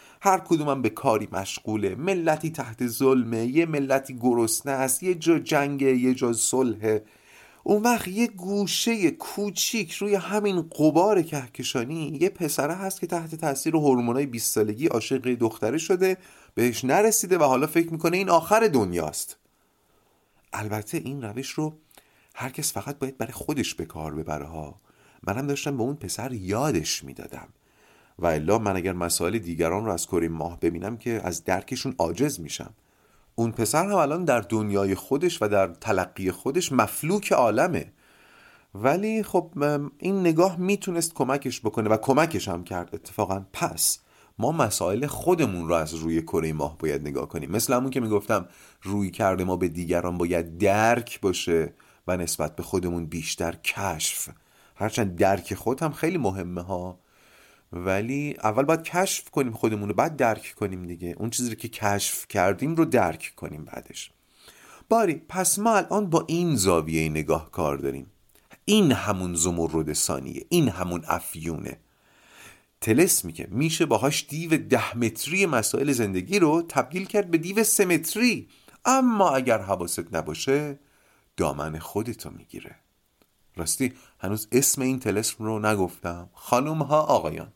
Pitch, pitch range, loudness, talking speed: 120 Hz, 95-160 Hz, -25 LUFS, 150 wpm